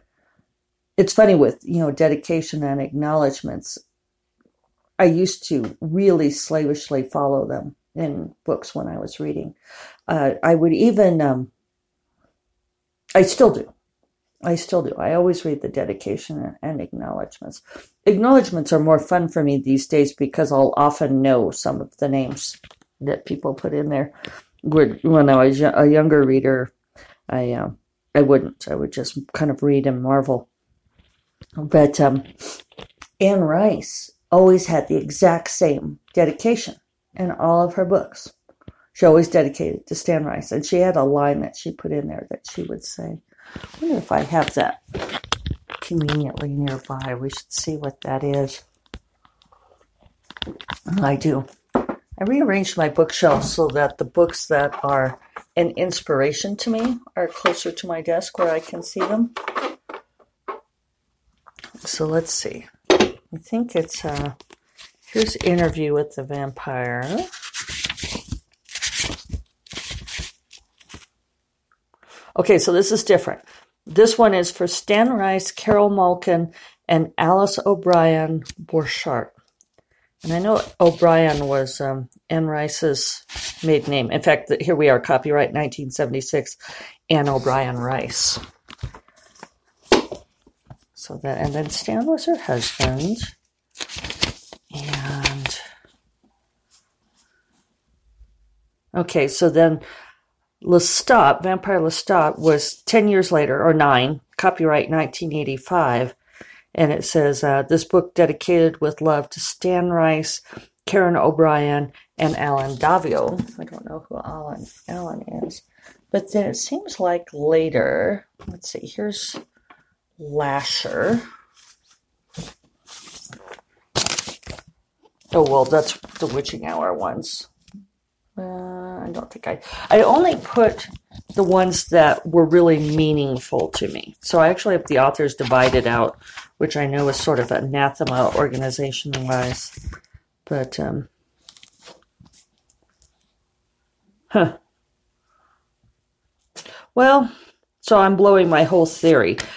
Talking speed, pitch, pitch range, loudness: 125 wpm, 155 Hz, 140-180 Hz, -19 LUFS